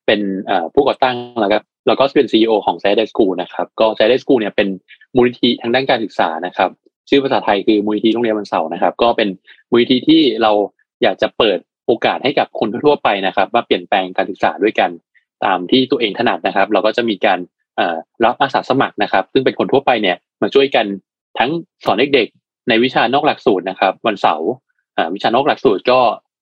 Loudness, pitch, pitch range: -15 LUFS, 110 Hz, 105-125 Hz